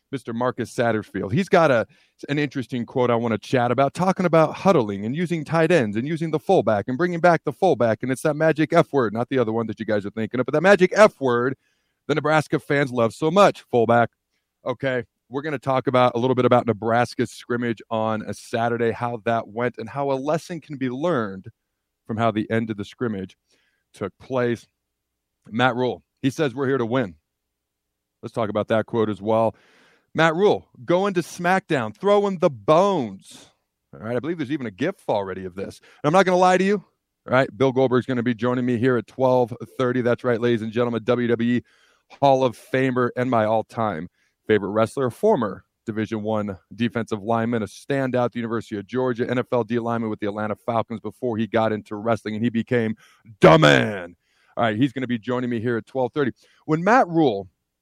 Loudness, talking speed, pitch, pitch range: -22 LUFS, 210 wpm, 120 Hz, 110-140 Hz